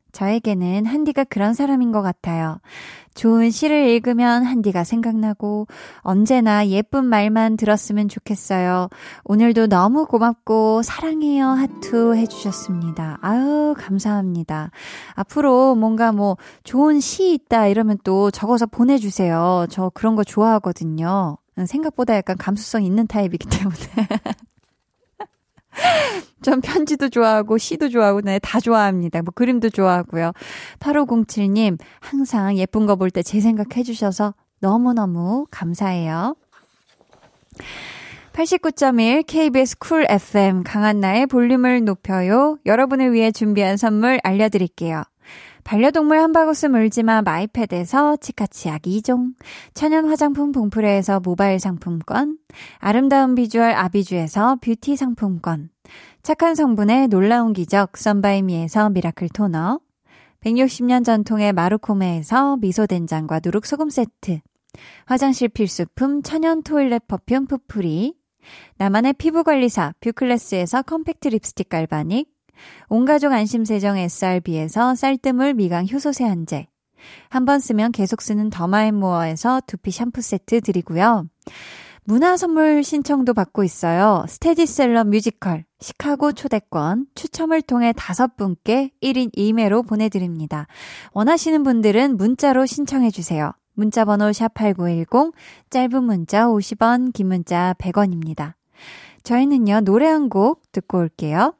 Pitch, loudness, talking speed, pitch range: 220 Hz, -18 LUFS, 285 characters per minute, 195-260 Hz